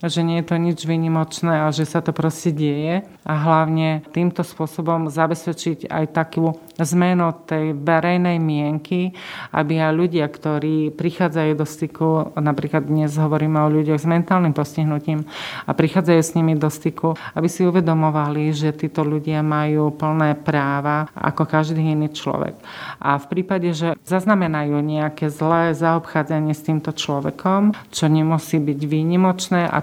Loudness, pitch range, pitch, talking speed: -20 LUFS, 155-170 Hz, 160 Hz, 145 wpm